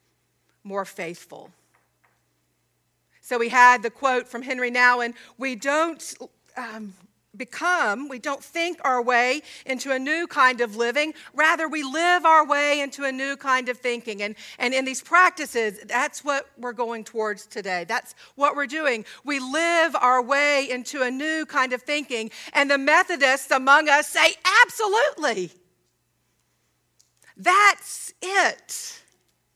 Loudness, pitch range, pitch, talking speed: -22 LUFS, 240-310 Hz, 265 Hz, 140 wpm